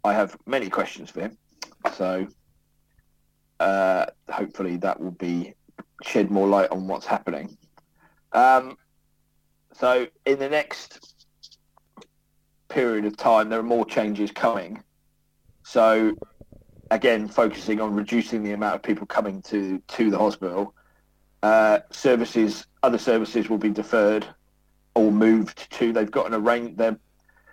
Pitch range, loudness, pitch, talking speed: 95-115 Hz, -23 LUFS, 105 Hz, 130 wpm